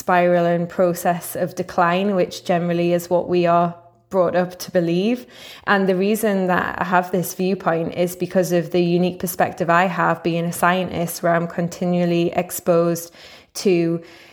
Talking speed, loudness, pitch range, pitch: 165 wpm, -20 LUFS, 170-185 Hz, 175 Hz